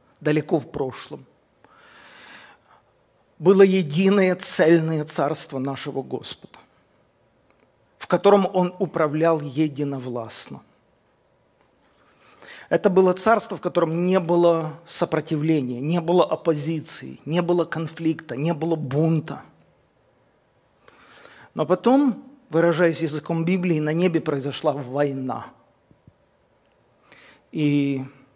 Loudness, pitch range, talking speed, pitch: -22 LUFS, 150-175 Hz, 85 wpm, 165 Hz